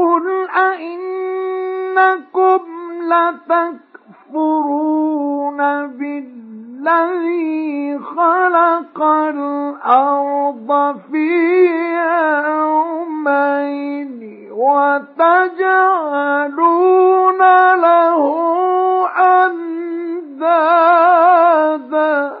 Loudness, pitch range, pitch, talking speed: -14 LUFS, 285-355 Hz, 335 Hz, 30 wpm